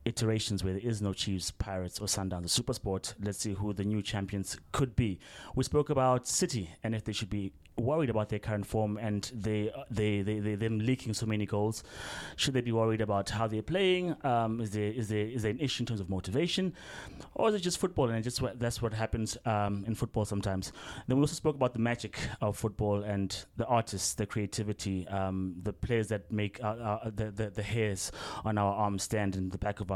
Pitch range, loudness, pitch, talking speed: 100-115 Hz, -33 LUFS, 110 Hz, 235 wpm